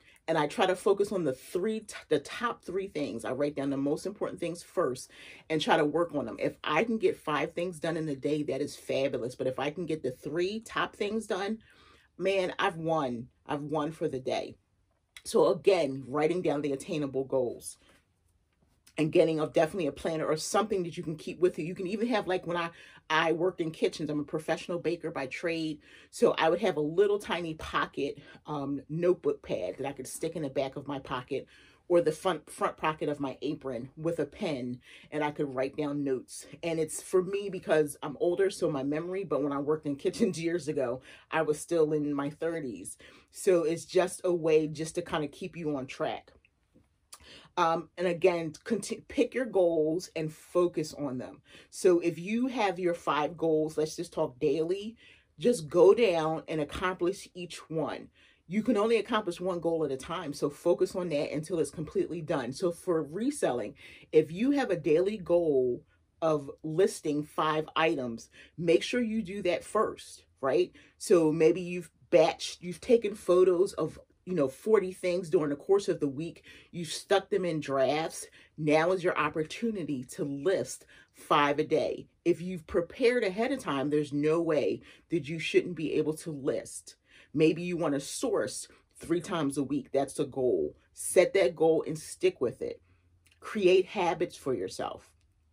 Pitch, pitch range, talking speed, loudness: 165 Hz, 150-185 Hz, 195 wpm, -30 LUFS